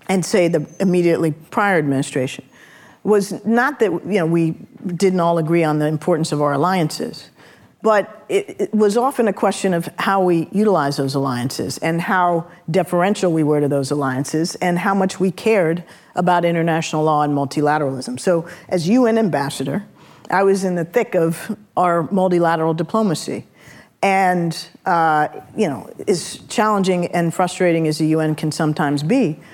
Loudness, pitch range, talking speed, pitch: -18 LUFS, 155-195 Hz, 160 wpm, 175 Hz